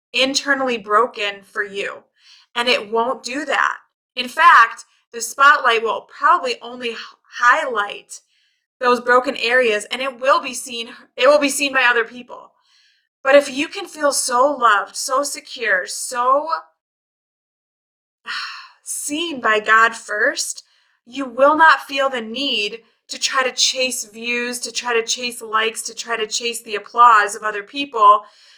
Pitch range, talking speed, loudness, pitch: 230-275 Hz, 150 wpm, -17 LUFS, 245 Hz